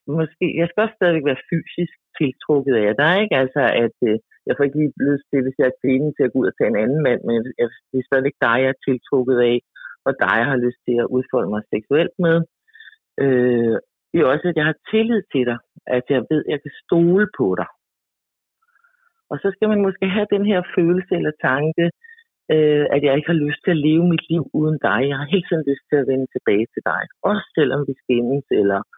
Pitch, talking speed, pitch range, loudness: 145 Hz, 230 wpm, 130-175 Hz, -19 LUFS